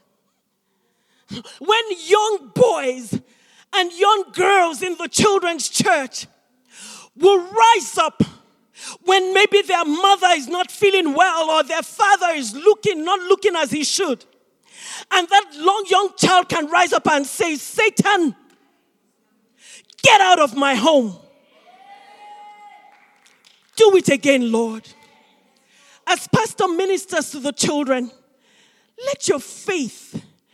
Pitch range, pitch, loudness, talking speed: 265-395 Hz, 335 Hz, -17 LUFS, 120 wpm